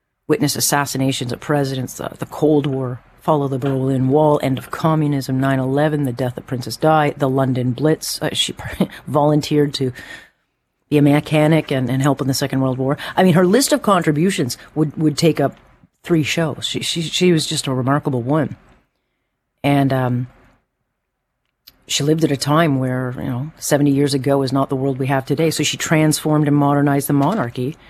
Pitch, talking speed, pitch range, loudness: 140 Hz, 185 wpm, 135-155 Hz, -18 LUFS